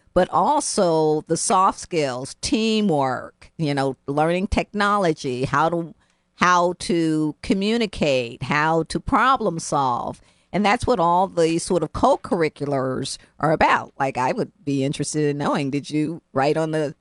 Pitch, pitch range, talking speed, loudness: 160 Hz, 140-180 Hz, 150 wpm, -21 LUFS